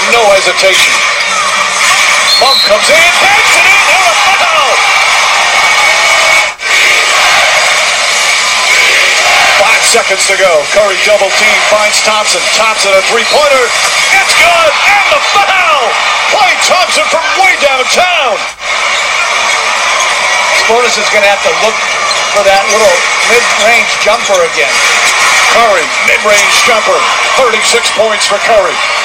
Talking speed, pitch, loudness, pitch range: 105 wpm, 220 Hz, -6 LUFS, 205-315 Hz